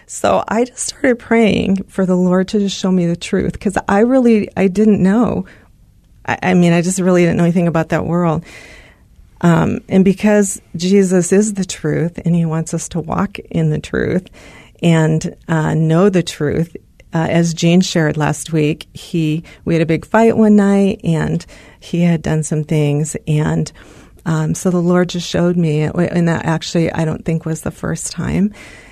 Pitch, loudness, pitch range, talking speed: 170 Hz, -15 LUFS, 160-195 Hz, 190 wpm